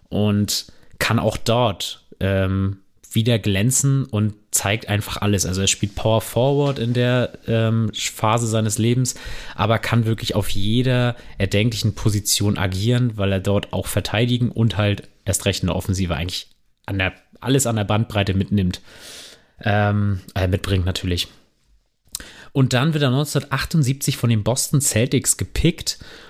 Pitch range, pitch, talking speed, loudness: 100-120 Hz, 105 Hz, 145 wpm, -20 LUFS